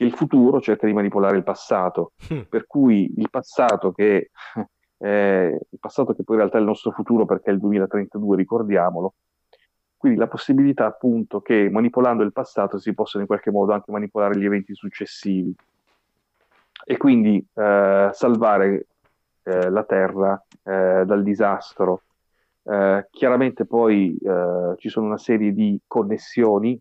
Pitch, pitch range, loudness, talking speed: 100 Hz, 100-110 Hz, -20 LUFS, 150 wpm